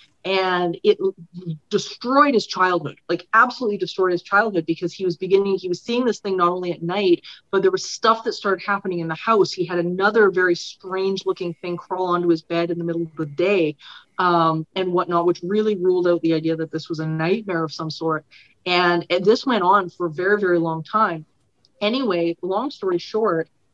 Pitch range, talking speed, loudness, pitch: 170-200 Hz, 205 wpm, -21 LUFS, 180 Hz